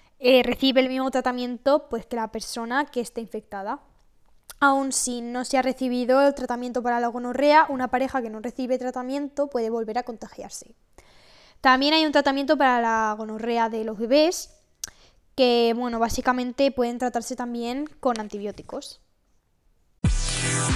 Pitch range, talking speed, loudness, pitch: 230-265 Hz, 145 wpm, -24 LUFS, 245 Hz